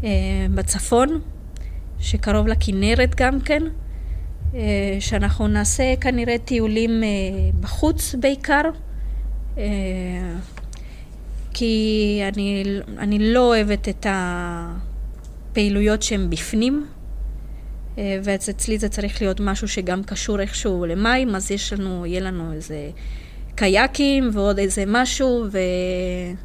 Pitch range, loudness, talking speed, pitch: 145-220 Hz, -21 LUFS, 100 wpm, 195 Hz